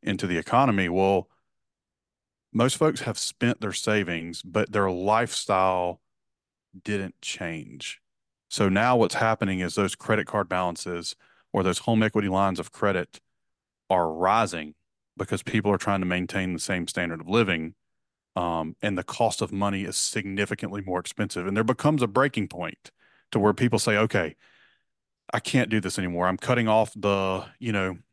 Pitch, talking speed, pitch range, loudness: 100 Hz, 160 wpm, 90-110 Hz, -26 LUFS